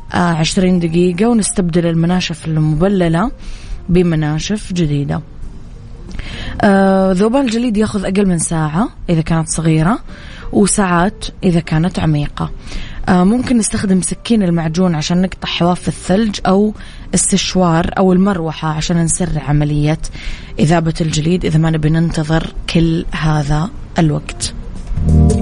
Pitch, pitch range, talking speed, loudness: 170 Hz, 155-190 Hz, 110 wpm, -14 LUFS